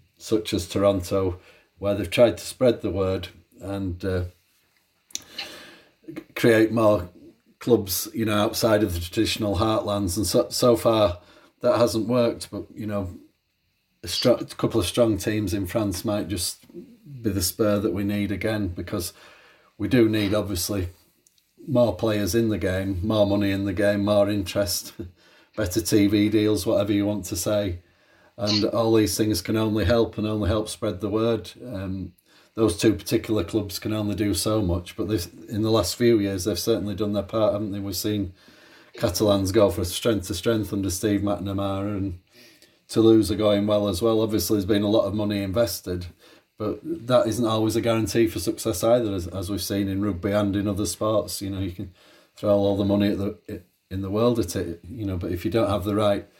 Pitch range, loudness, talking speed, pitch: 100-110 Hz, -24 LUFS, 195 wpm, 105 Hz